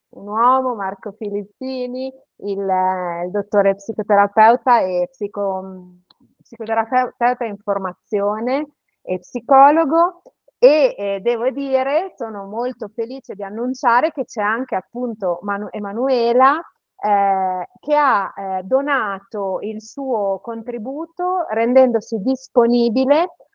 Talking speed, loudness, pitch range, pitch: 100 wpm, -18 LUFS, 200-265 Hz, 230 Hz